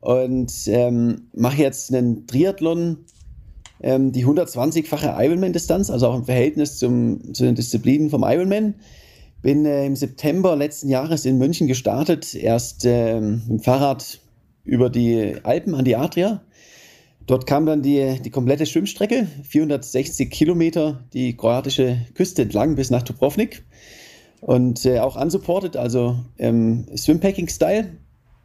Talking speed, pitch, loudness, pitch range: 135 wpm, 135 Hz, -20 LUFS, 120-160 Hz